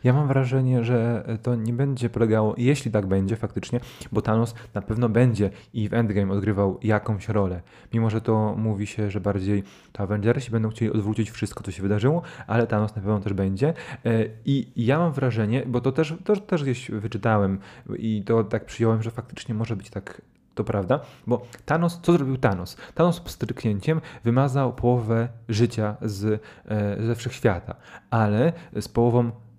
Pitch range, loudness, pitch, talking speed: 105-125 Hz, -24 LUFS, 115 Hz, 170 wpm